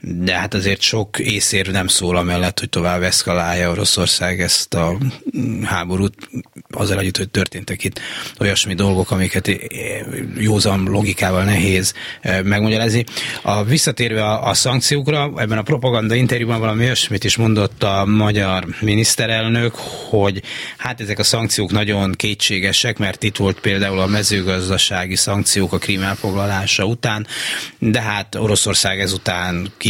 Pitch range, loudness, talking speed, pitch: 95-110 Hz, -17 LUFS, 130 wpm, 100 Hz